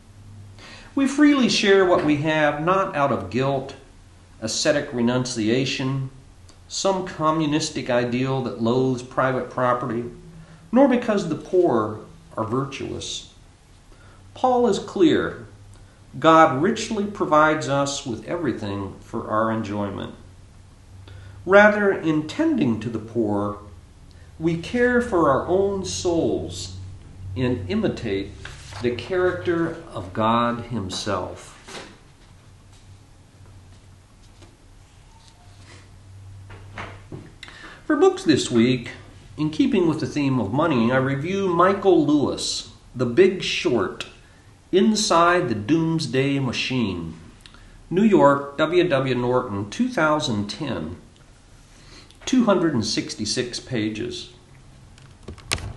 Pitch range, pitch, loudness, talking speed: 100-160 Hz, 120 Hz, -21 LUFS, 95 wpm